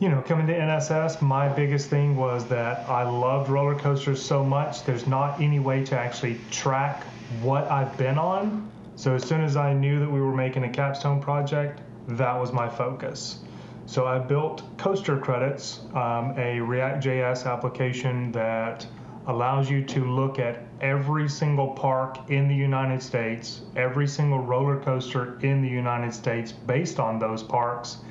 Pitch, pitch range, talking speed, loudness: 130 Hz, 125-140 Hz, 165 wpm, -26 LUFS